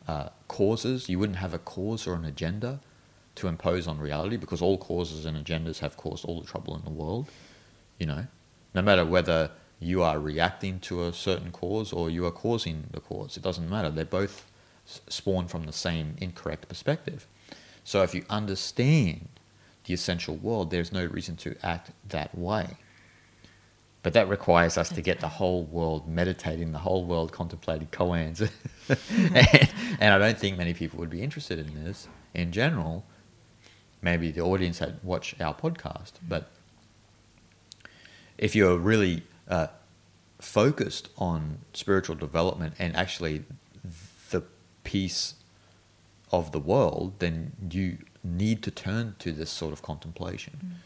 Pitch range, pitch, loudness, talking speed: 85-105 Hz, 90 Hz, -28 LUFS, 155 wpm